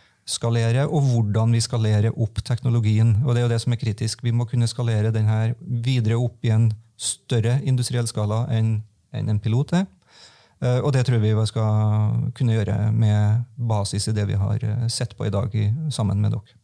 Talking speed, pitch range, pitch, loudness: 200 wpm, 110-120 Hz, 115 Hz, -22 LUFS